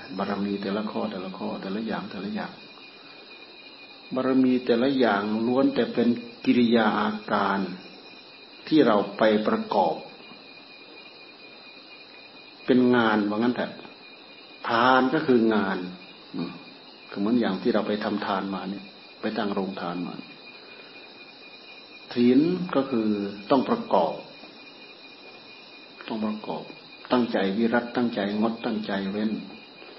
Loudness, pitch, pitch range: -25 LUFS, 110 Hz, 100-120 Hz